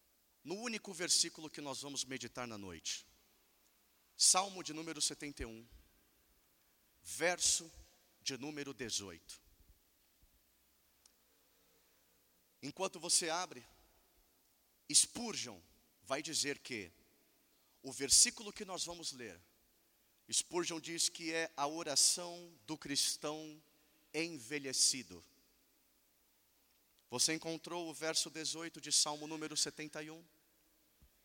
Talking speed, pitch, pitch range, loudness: 90 wpm, 150 Hz, 125-165 Hz, -36 LUFS